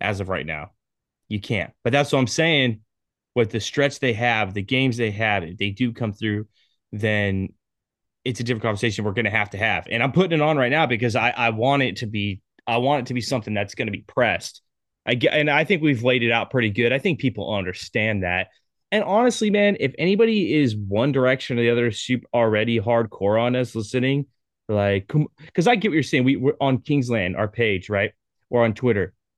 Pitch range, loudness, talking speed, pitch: 105-135 Hz, -22 LUFS, 225 wpm, 120 Hz